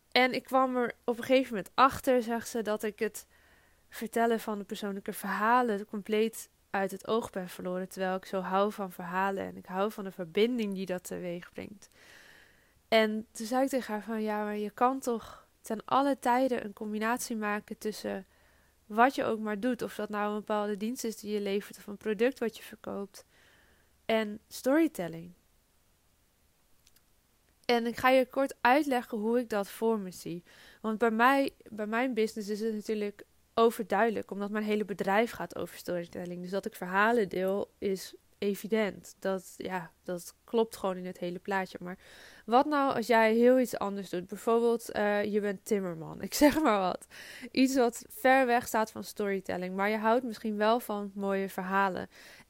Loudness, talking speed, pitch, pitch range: -31 LUFS, 185 wpm, 215 Hz, 195-235 Hz